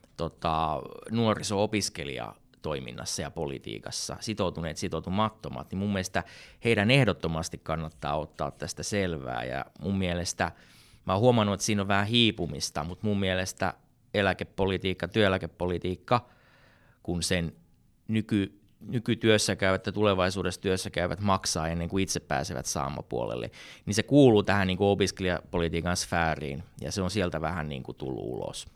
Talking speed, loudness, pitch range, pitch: 130 wpm, -29 LUFS, 80-100 Hz, 95 Hz